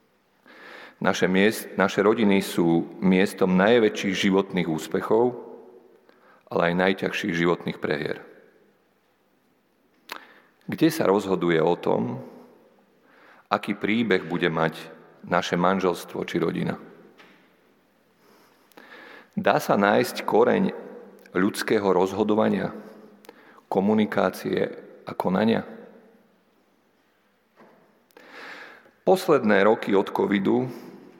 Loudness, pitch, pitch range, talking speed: -23 LUFS, 95 Hz, 85-105 Hz, 75 wpm